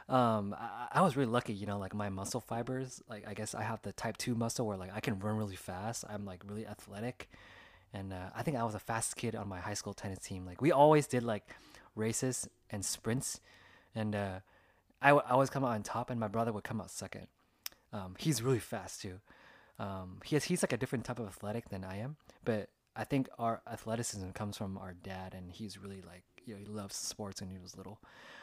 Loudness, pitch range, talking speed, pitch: -36 LUFS, 100-120 Hz, 235 wpm, 105 Hz